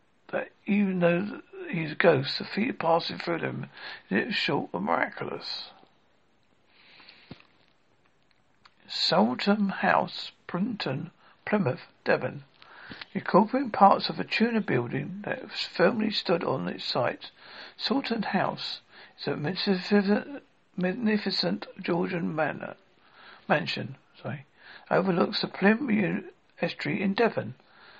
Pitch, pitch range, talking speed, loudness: 200 Hz, 185-225 Hz, 110 wpm, -28 LUFS